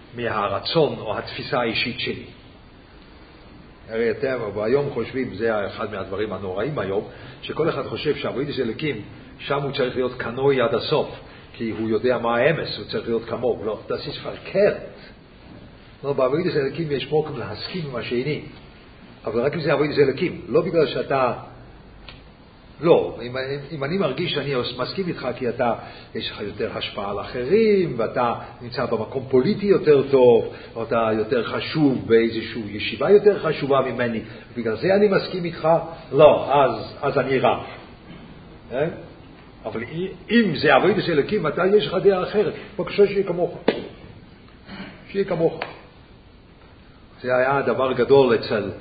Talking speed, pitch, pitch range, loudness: 145 wpm, 135 Hz, 115-175 Hz, -22 LUFS